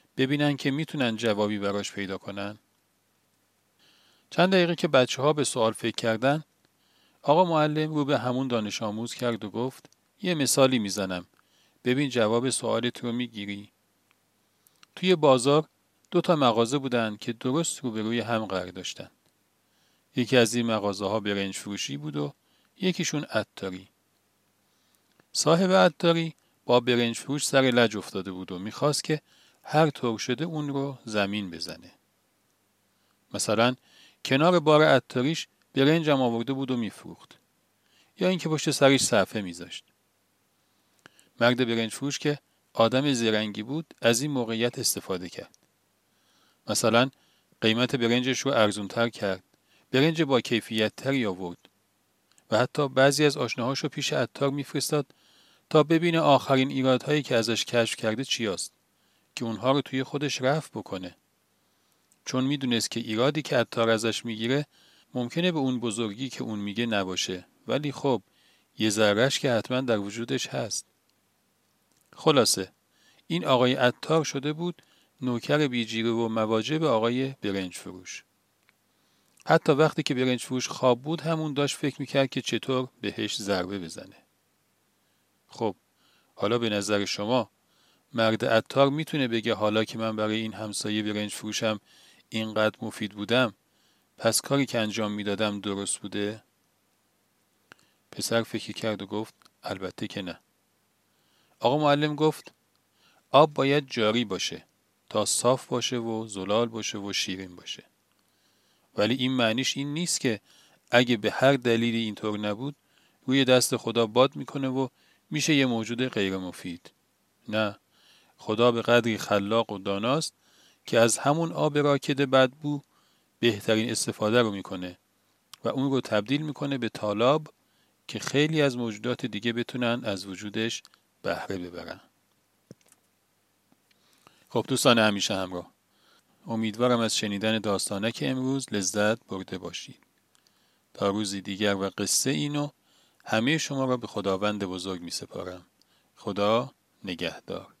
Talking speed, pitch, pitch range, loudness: 135 wpm, 120 Hz, 105-140 Hz, -26 LUFS